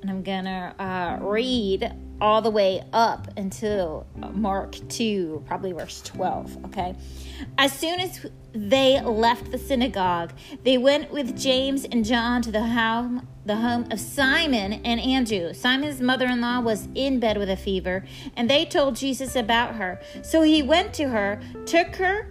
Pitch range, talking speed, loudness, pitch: 195-265 Hz, 160 wpm, -24 LUFS, 235 Hz